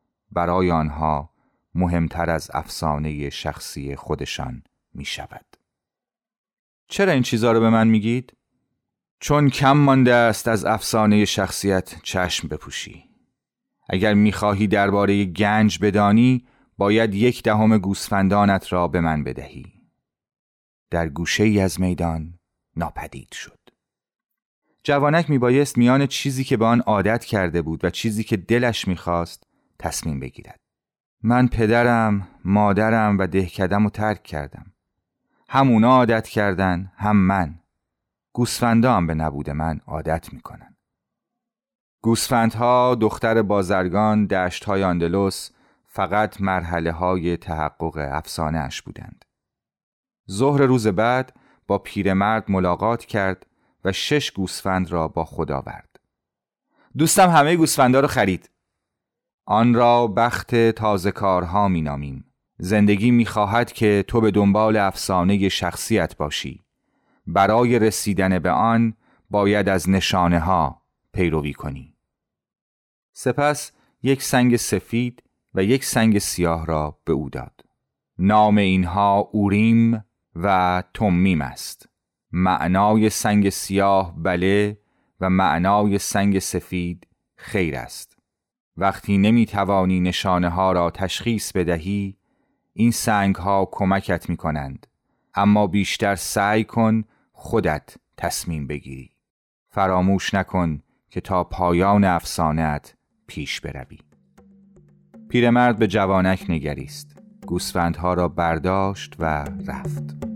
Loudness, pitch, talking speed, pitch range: -20 LUFS, 100 Hz, 115 wpm, 90-115 Hz